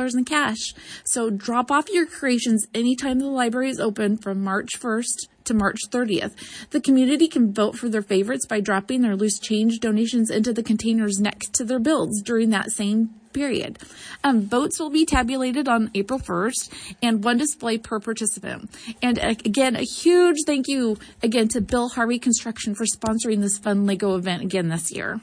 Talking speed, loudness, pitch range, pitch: 180 wpm, -22 LUFS, 215-255 Hz, 230 Hz